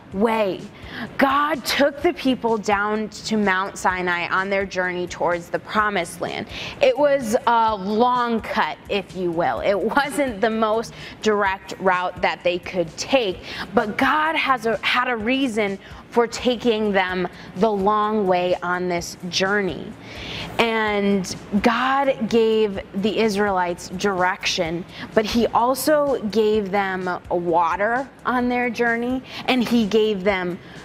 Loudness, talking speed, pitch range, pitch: -21 LUFS, 135 wpm, 185-240 Hz, 210 Hz